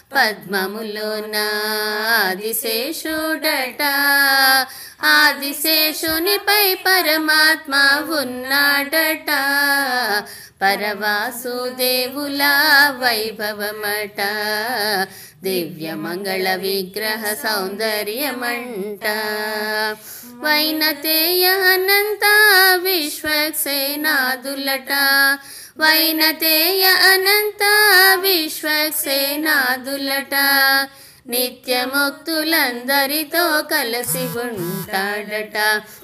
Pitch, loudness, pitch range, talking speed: 275 Hz, -16 LUFS, 215-310 Hz, 30 wpm